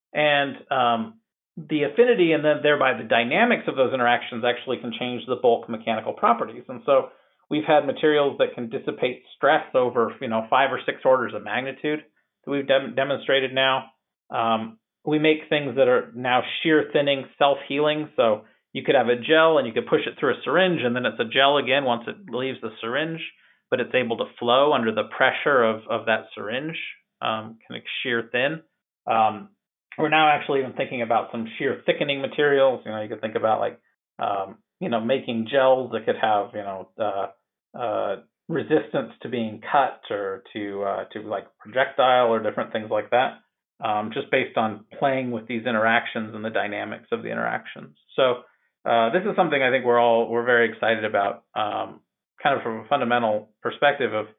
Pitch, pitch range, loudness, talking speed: 130 Hz, 115-150 Hz, -23 LUFS, 195 wpm